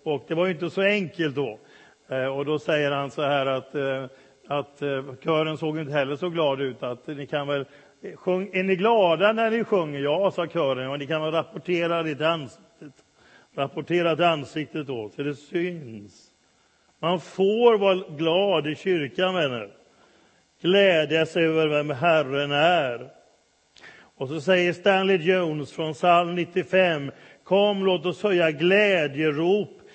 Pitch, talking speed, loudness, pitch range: 160 Hz, 145 wpm, -24 LUFS, 145-185 Hz